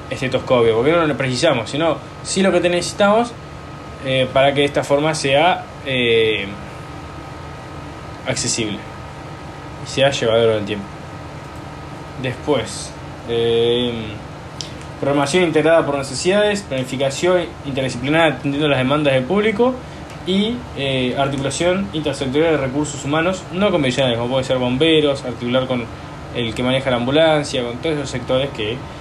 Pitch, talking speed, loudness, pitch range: 140 Hz, 130 wpm, -18 LUFS, 130-160 Hz